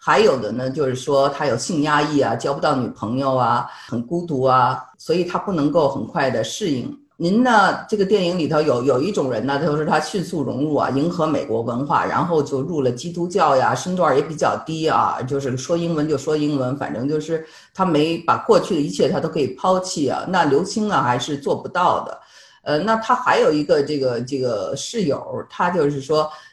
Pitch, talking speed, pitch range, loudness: 150 Hz, 305 characters per minute, 135-175 Hz, -20 LUFS